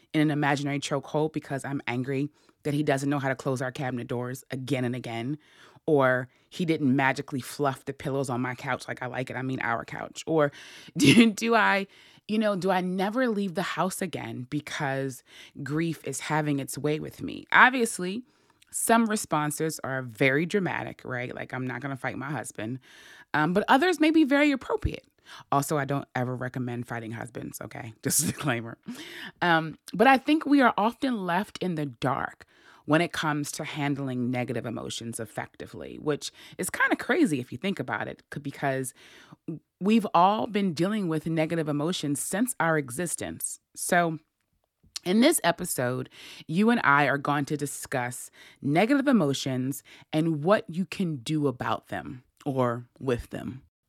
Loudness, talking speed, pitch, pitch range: -27 LUFS, 170 wpm, 145 Hz, 130-180 Hz